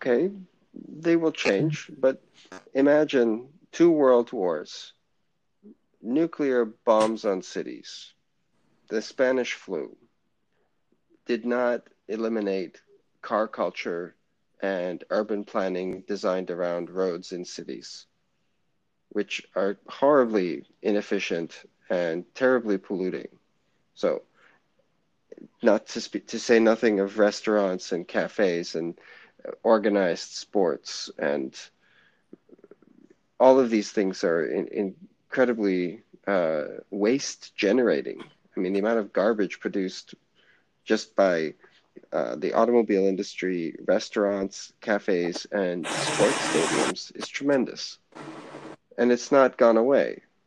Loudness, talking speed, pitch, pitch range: -25 LUFS, 105 wpm, 110 Hz, 95-130 Hz